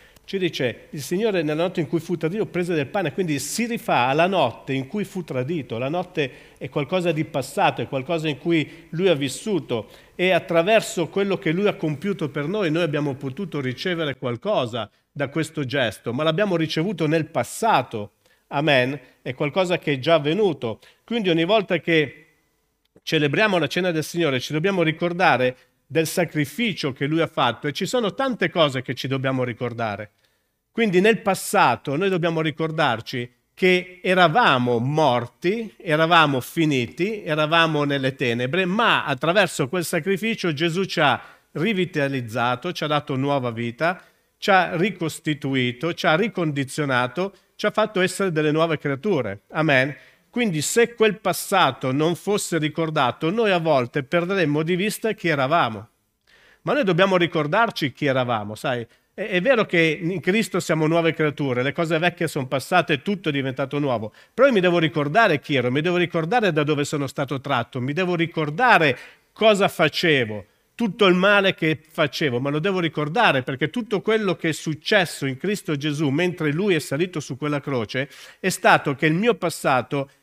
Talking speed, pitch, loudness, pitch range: 170 wpm, 160 Hz, -22 LUFS, 140-180 Hz